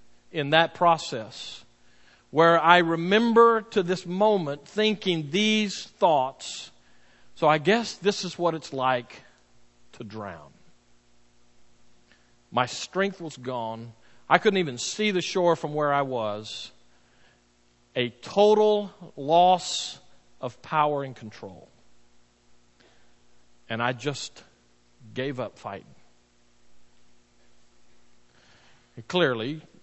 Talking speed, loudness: 105 wpm, -24 LUFS